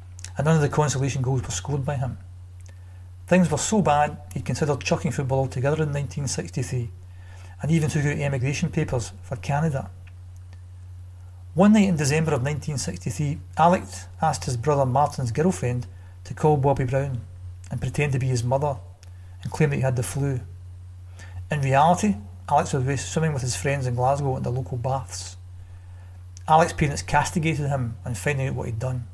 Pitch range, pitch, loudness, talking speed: 90-145 Hz, 130 Hz, -24 LUFS, 170 wpm